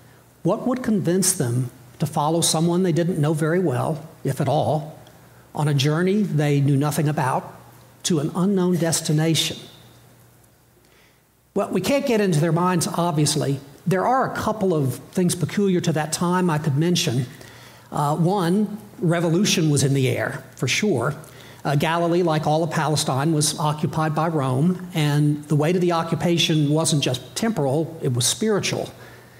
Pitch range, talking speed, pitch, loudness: 150-175 Hz, 160 wpm, 160 Hz, -21 LUFS